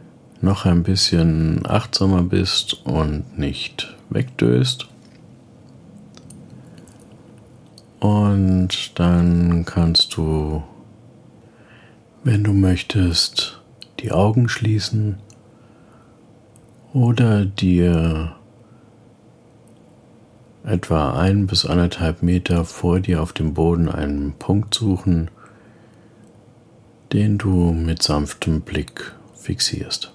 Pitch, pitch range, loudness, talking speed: 95 Hz, 85-110 Hz, -19 LUFS, 80 wpm